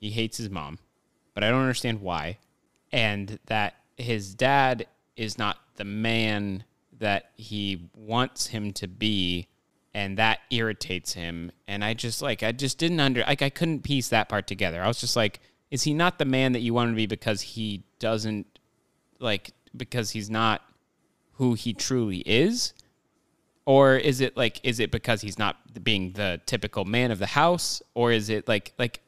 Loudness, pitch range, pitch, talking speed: -26 LUFS, 105-125 Hz, 110 Hz, 185 wpm